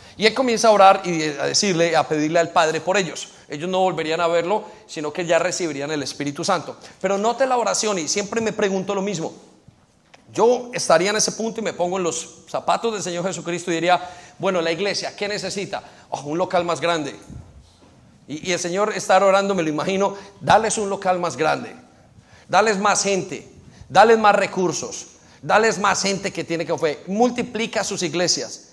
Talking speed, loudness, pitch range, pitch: 190 wpm, -20 LUFS, 170-205 Hz, 185 Hz